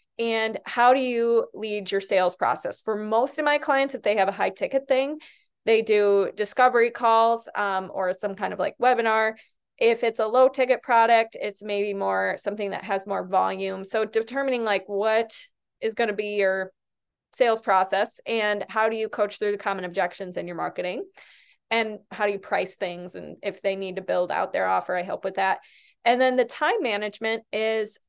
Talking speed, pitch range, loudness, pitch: 200 wpm, 195-235 Hz, -24 LUFS, 215 Hz